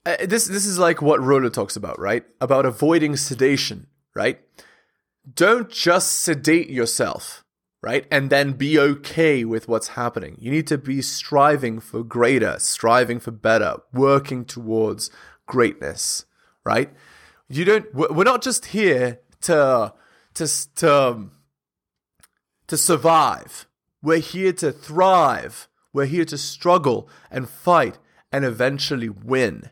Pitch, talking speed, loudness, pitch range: 140 Hz, 130 wpm, -20 LUFS, 125-165 Hz